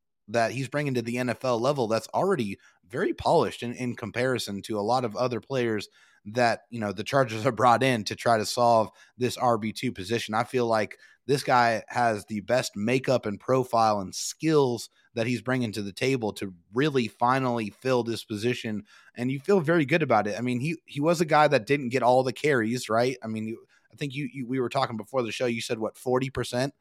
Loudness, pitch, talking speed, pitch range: -26 LUFS, 120 Hz, 225 wpm, 110-130 Hz